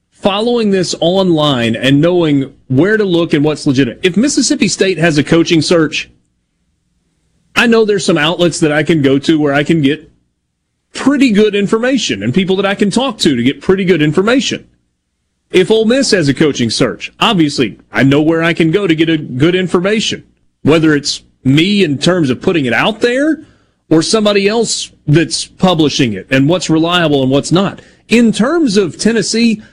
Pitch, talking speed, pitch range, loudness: 170 Hz, 185 wpm, 140-205 Hz, -12 LUFS